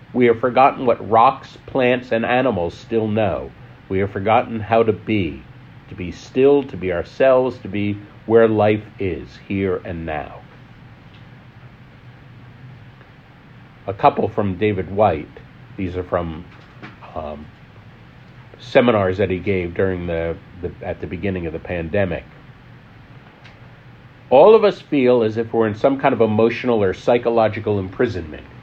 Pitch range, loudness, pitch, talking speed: 95-125 Hz, -18 LUFS, 110 Hz, 140 wpm